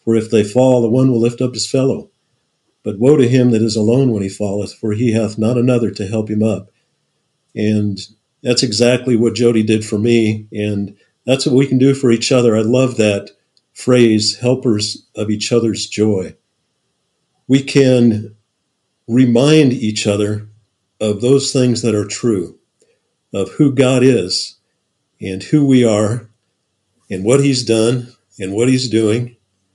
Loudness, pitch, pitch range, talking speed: -14 LUFS, 115 Hz, 105-125 Hz, 165 wpm